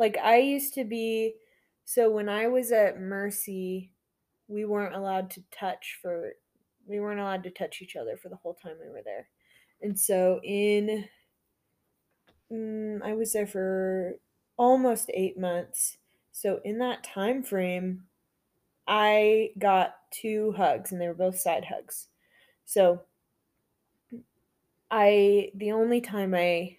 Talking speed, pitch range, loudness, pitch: 140 wpm, 190-225 Hz, -27 LUFS, 205 Hz